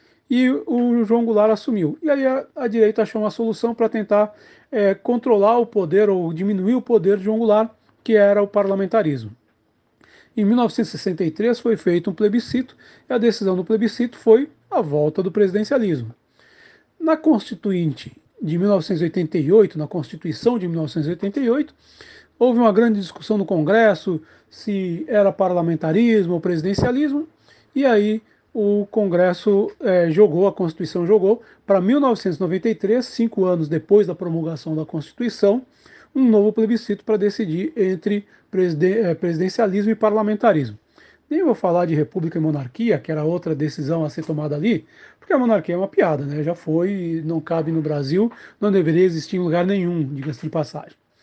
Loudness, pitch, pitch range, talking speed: -20 LUFS, 200 Hz, 170-225 Hz, 150 wpm